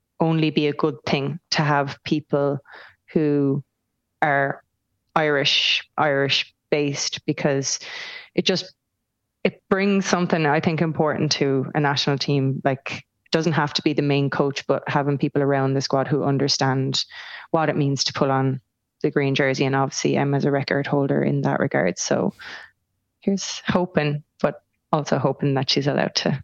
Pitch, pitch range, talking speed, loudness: 145 Hz, 135-155 Hz, 165 wpm, -22 LUFS